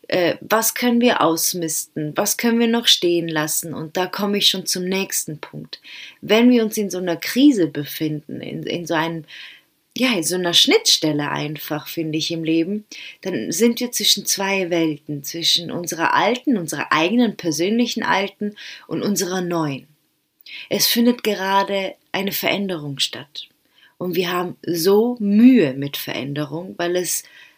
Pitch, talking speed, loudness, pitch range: 180 Hz, 155 wpm, -19 LUFS, 160-210 Hz